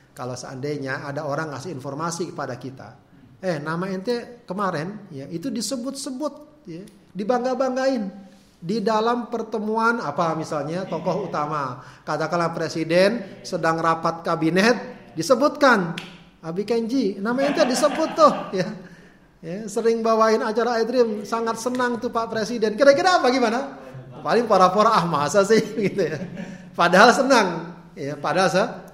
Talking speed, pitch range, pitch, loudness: 130 wpm, 165-235 Hz, 190 Hz, -22 LUFS